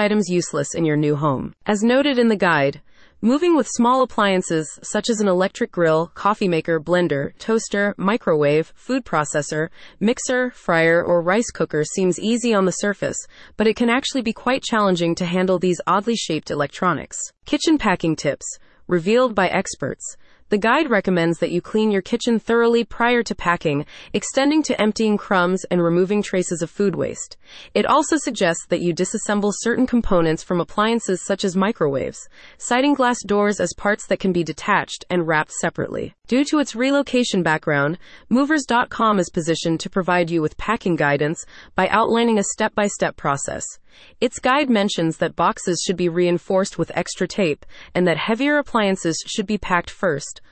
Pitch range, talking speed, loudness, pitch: 170-230 Hz, 165 wpm, -20 LUFS, 195 Hz